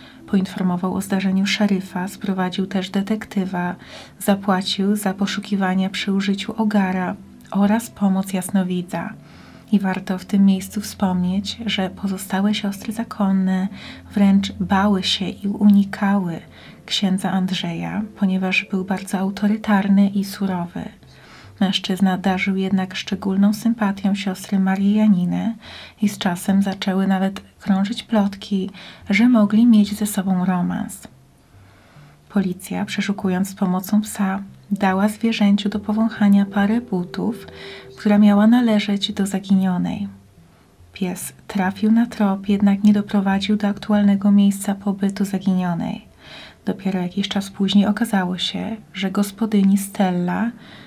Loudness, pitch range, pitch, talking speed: -20 LUFS, 190-205 Hz, 200 Hz, 115 wpm